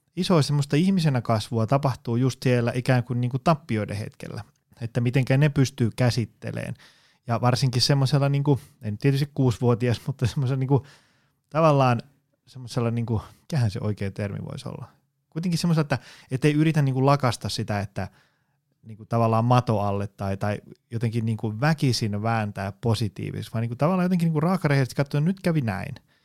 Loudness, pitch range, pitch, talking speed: -24 LUFS, 115-145 Hz, 130 Hz, 165 wpm